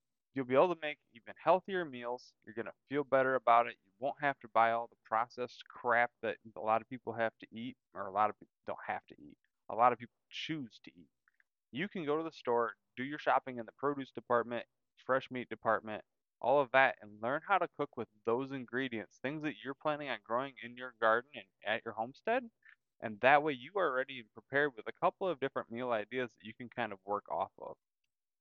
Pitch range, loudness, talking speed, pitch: 115-140 Hz, -35 LUFS, 230 wpm, 125 Hz